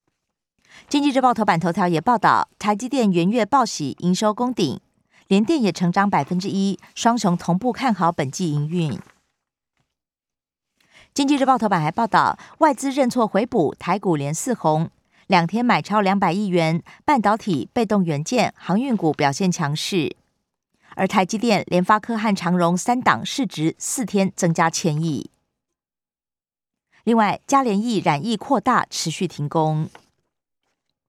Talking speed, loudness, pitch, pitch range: 225 characters per minute, -20 LUFS, 195 Hz, 170-230 Hz